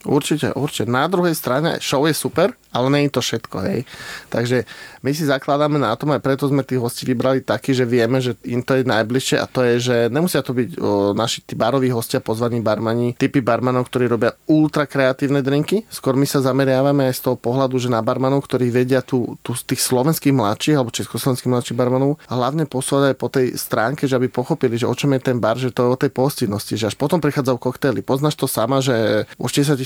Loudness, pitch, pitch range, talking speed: -19 LUFS, 130 Hz, 120-140 Hz, 220 wpm